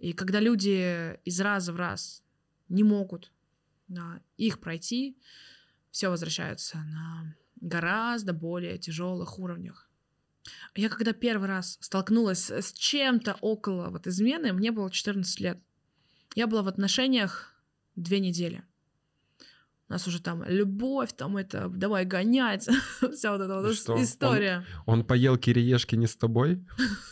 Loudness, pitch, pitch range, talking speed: -28 LUFS, 185 Hz, 165-210 Hz, 130 wpm